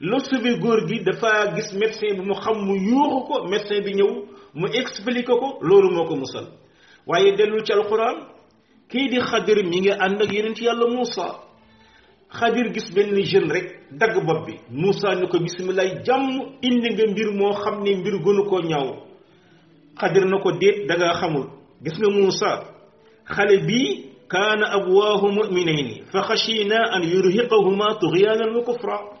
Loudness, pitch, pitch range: -20 LUFS, 205 Hz, 190-230 Hz